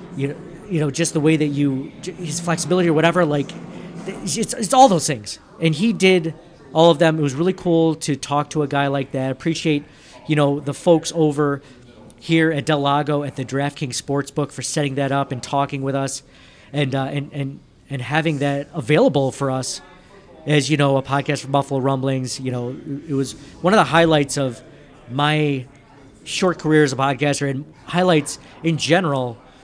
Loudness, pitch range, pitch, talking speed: -20 LUFS, 135-165 Hz, 145 Hz, 190 wpm